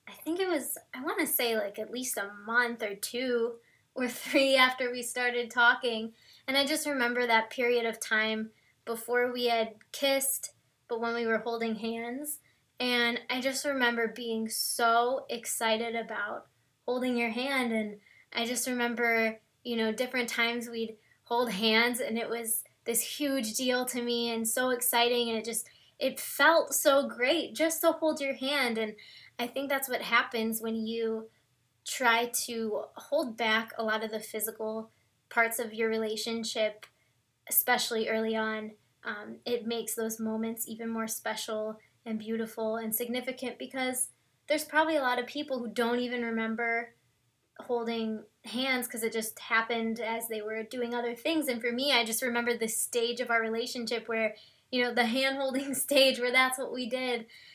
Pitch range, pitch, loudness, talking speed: 225-255 Hz, 235 Hz, -30 LUFS, 175 wpm